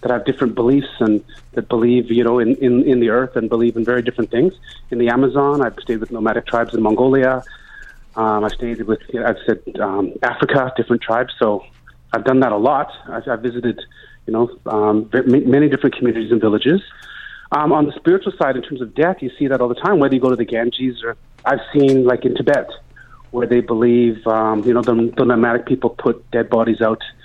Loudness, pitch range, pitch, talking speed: -17 LUFS, 115-130 Hz, 120 Hz, 220 wpm